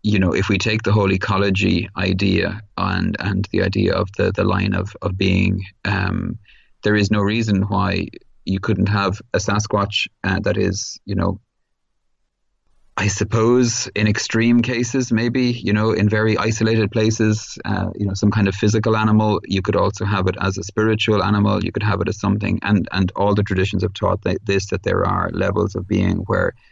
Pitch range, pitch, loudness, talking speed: 100-110 Hz, 105 Hz, -19 LUFS, 195 wpm